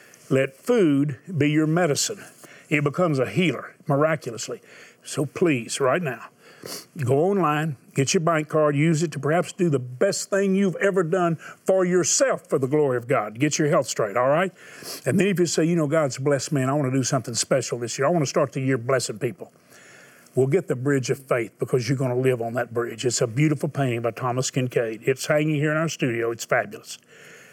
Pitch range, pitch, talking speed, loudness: 130-170 Hz, 145 Hz, 220 wpm, -23 LUFS